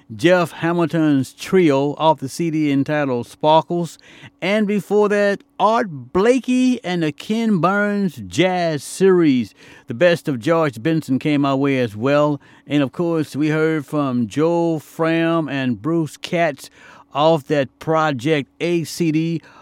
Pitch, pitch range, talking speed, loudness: 160 Hz, 140-170 Hz, 140 wpm, -19 LUFS